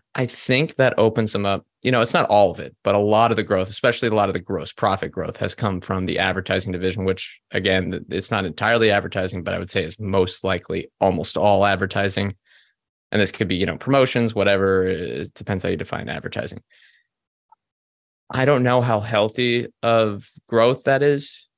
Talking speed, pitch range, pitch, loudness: 200 wpm, 95-115 Hz, 100 Hz, -21 LUFS